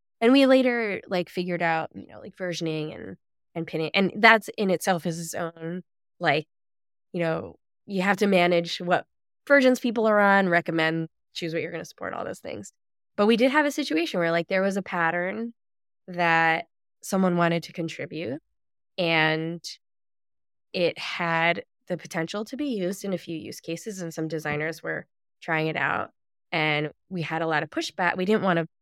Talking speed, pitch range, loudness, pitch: 185 wpm, 165-195 Hz, -25 LUFS, 175 Hz